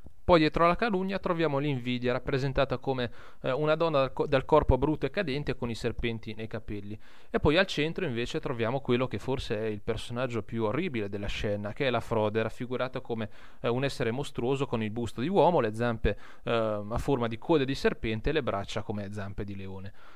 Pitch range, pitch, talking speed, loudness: 110-140 Hz, 120 Hz, 210 wpm, -30 LUFS